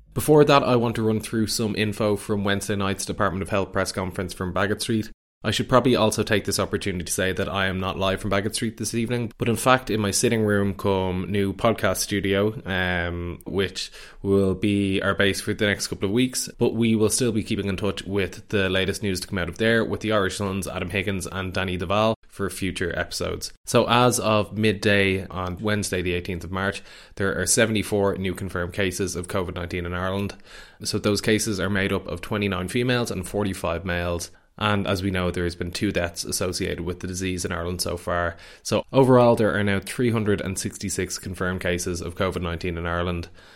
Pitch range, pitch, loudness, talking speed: 95-110 Hz, 100 Hz, -24 LUFS, 210 wpm